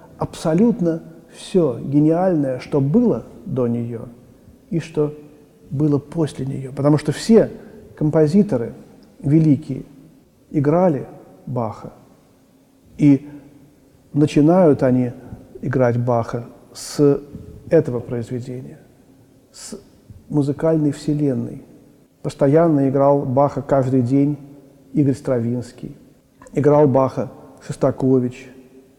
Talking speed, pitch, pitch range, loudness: 85 wpm, 140 Hz, 130-150 Hz, -19 LUFS